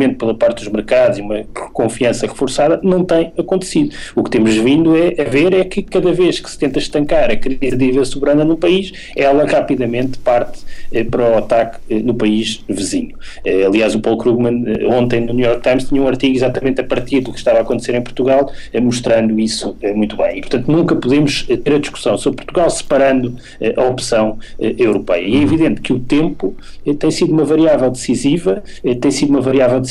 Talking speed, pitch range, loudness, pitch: 195 wpm, 120-150 Hz, -15 LUFS, 130 Hz